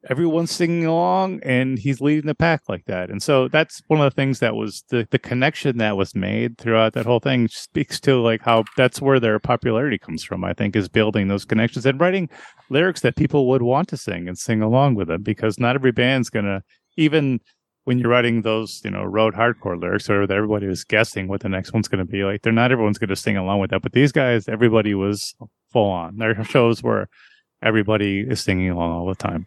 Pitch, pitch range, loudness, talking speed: 115 Hz, 100-135 Hz, -20 LUFS, 230 wpm